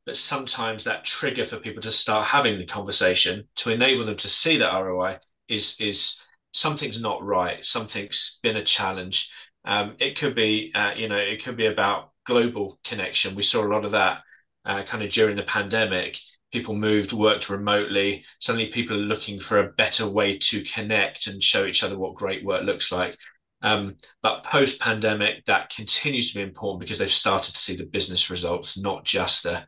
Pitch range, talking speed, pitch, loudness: 100-110 Hz, 190 wpm, 105 Hz, -23 LUFS